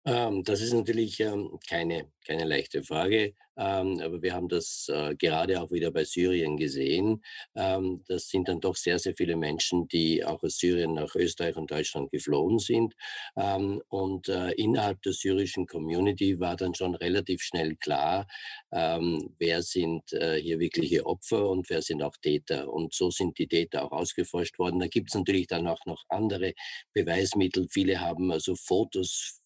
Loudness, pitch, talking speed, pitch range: -29 LUFS, 90 Hz, 175 wpm, 85-95 Hz